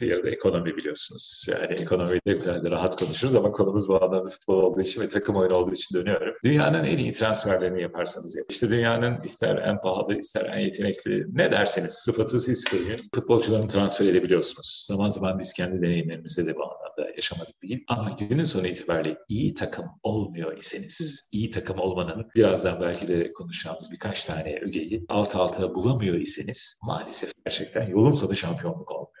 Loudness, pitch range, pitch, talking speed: -26 LUFS, 90-115 Hz, 95 Hz, 170 wpm